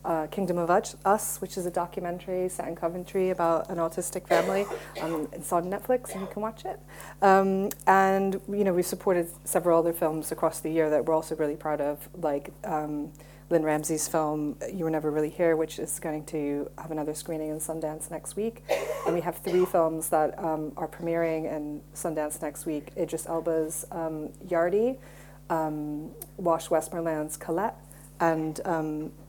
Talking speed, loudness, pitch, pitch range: 180 wpm, -28 LUFS, 165 Hz, 155-180 Hz